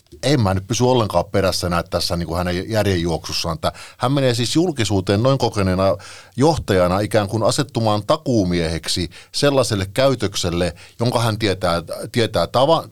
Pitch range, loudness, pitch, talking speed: 90-120 Hz, -19 LUFS, 100 Hz, 135 wpm